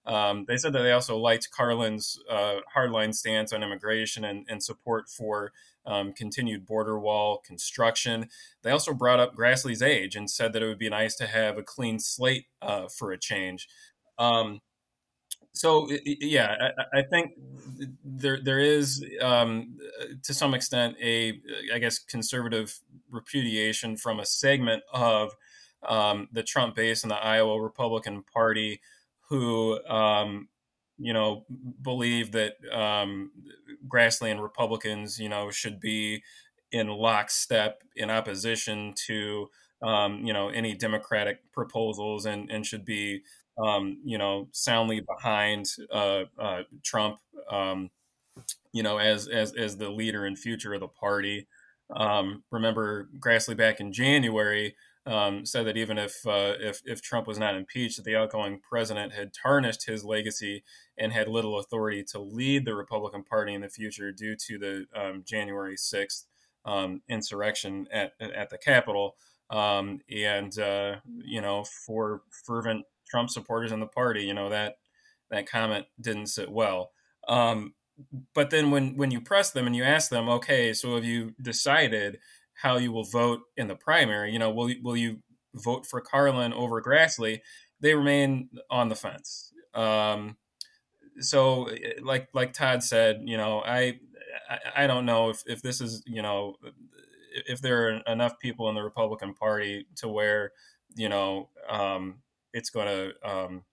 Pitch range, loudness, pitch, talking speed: 105-125 Hz, -28 LUFS, 110 Hz, 155 wpm